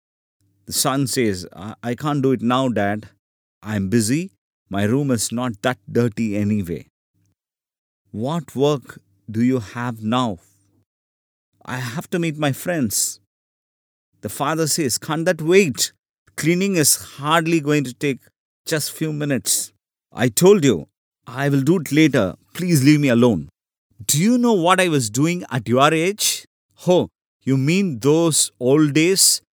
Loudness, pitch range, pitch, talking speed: -19 LUFS, 105-155 Hz, 130 Hz, 145 wpm